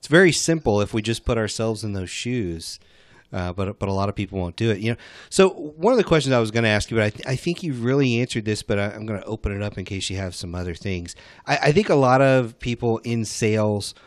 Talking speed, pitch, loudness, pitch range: 285 wpm, 110 Hz, -22 LUFS, 100-125 Hz